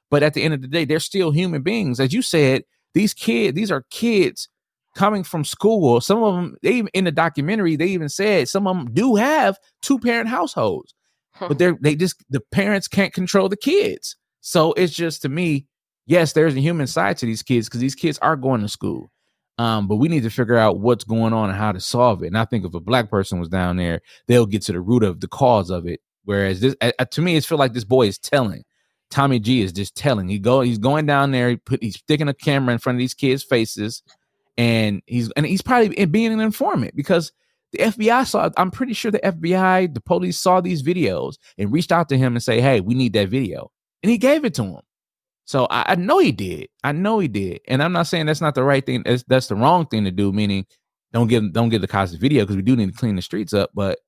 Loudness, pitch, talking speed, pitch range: -19 LUFS, 140 Hz, 250 wpm, 115-185 Hz